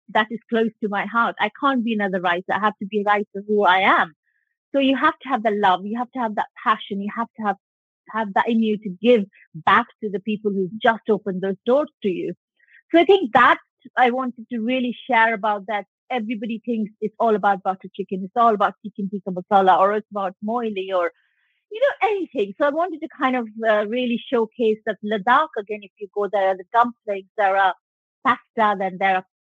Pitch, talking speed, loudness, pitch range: 220 Hz, 225 wpm, -21 LUFS, 200-245 Hz